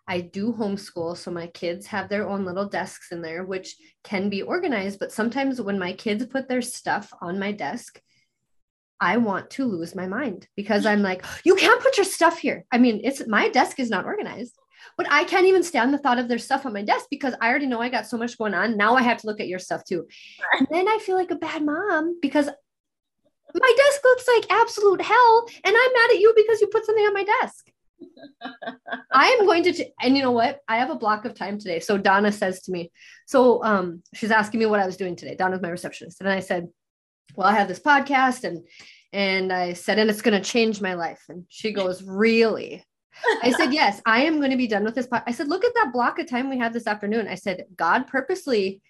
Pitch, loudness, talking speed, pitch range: 230 Hz, -22 LUFS, 235 wpm, 195-300 Hz